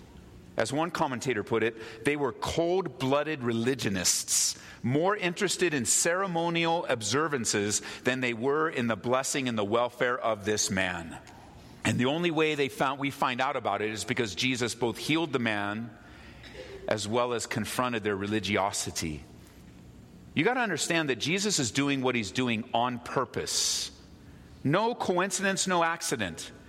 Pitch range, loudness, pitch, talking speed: 105-145 Hz, -28 LUFS, 120 Hz, 150 wpm